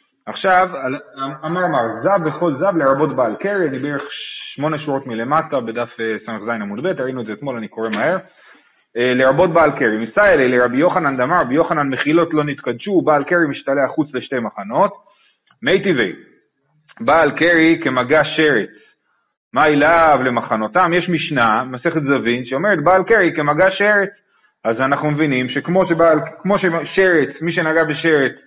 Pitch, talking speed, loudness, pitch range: 150 Hz, 150 wpm, -16 LUFS, 130-170 Hz